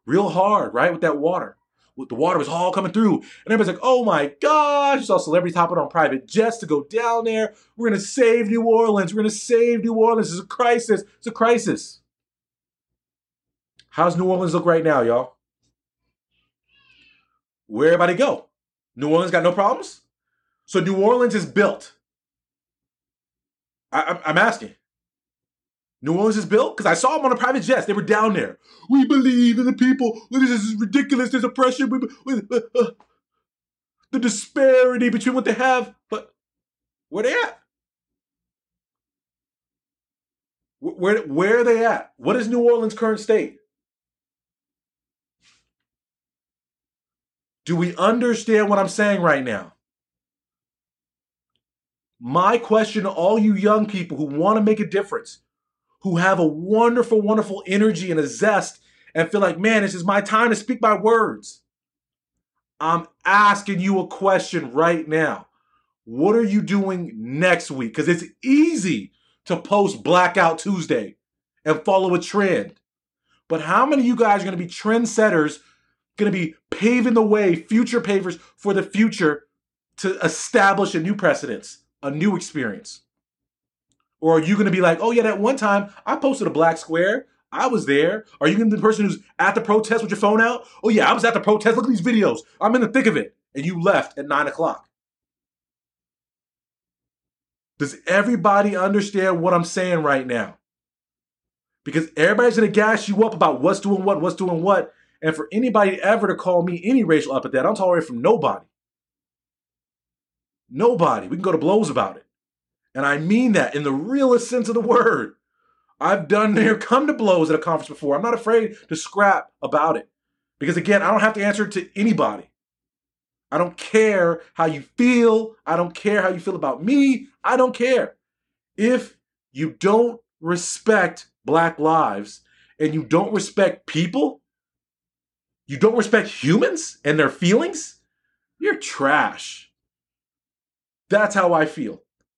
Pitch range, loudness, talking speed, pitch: 165-230 Hz, -19 LUFS, 170 wpm, 200 Hz